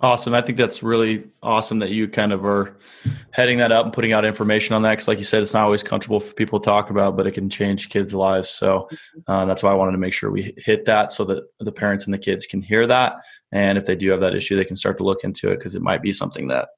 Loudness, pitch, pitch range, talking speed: -20 LUFS, 105 Hz, 95-115 Hz, 290 wpm